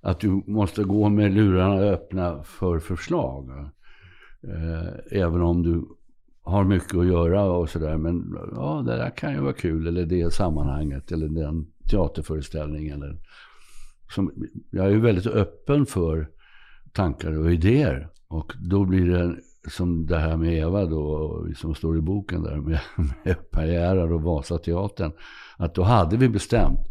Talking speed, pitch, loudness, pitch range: 150 wpm, 85 Hz, -24 LUFS, 80-95 Hz